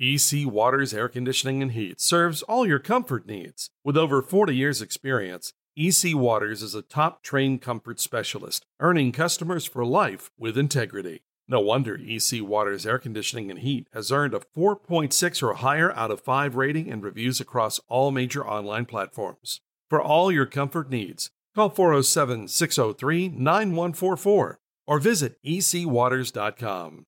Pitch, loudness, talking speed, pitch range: 135 Hz, -24 LUFS, 145 wpm, 120-165 Hz